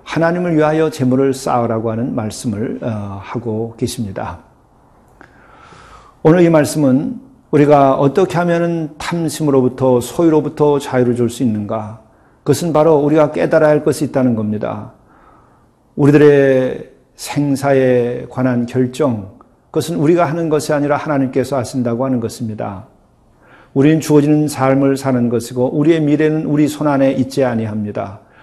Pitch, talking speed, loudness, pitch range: 135 Hz, 315 characters per minute, -15 LUFS, 120-150 Hz